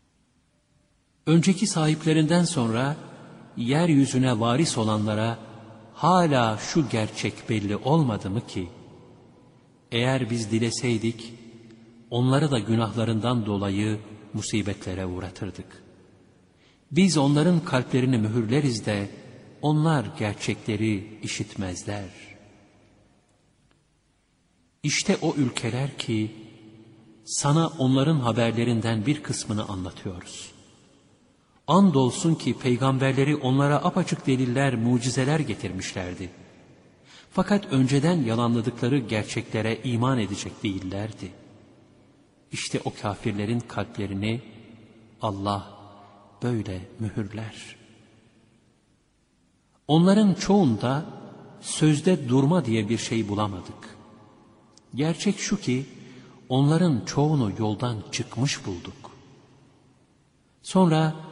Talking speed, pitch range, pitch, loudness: 75 wpm, 105-140 Hz, 115 Hz, -25 LUFS